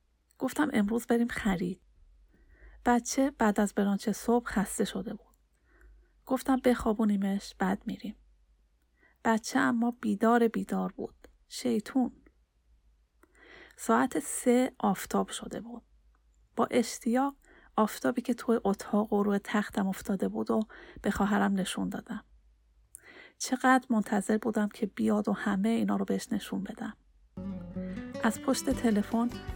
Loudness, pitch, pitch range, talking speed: -30 LUFS, 220 Hz, 195-240 Hz, 120 wpm